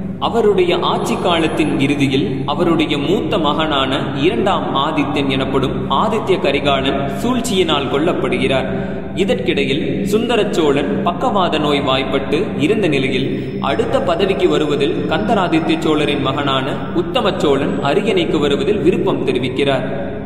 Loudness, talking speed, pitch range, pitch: -16 LUFS, 95 wpm, 140-185 Hz, 160 Hz